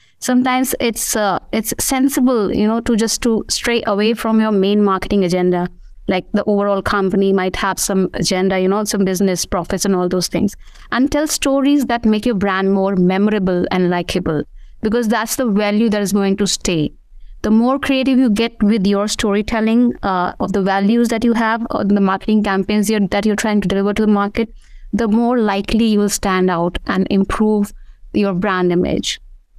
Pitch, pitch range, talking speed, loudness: 205 Hz, 190-230 Hz, 190 wpm, -16 LUFS